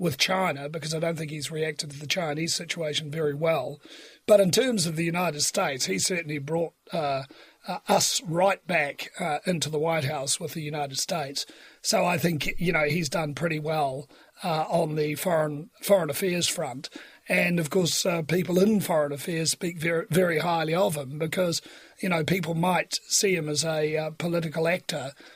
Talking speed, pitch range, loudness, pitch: 190 wpm, 150-180 Hz, -26 LUFS, 165 Hz